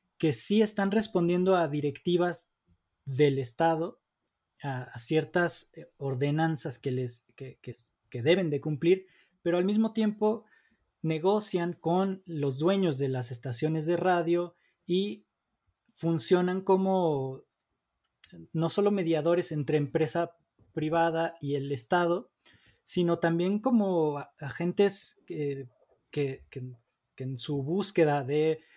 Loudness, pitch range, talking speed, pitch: -29 LUFS, 145-180 Hz, 120 wpm, 165 Hz